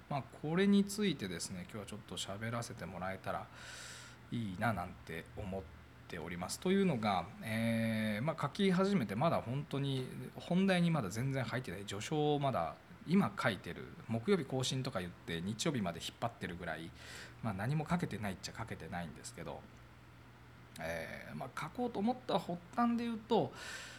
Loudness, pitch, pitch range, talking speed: -38 LUFS, 120 Hz, 95-160 Hz, 360 characters per minute